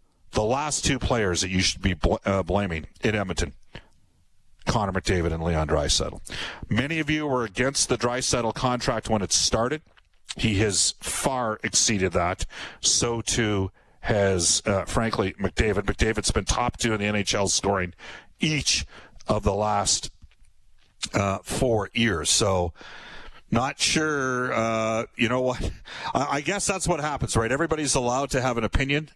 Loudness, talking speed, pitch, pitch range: -24 LUFS, 155 wpm, 110 Hz, 95-125 Hz